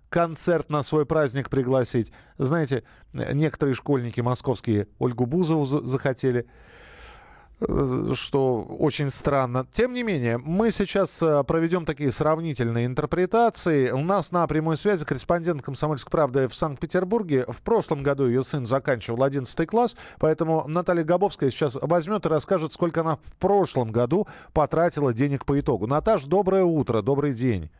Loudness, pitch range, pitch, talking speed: -24 LUFS, 130-170 Hz, 150 Hz, 135 wpm